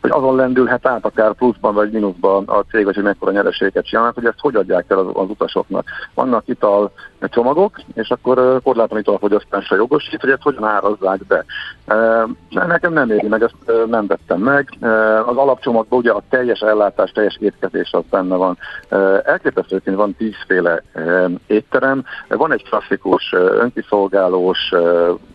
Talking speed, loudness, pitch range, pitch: 150 wpm, -16 LUFS, 100-125 Hz, 110 Hz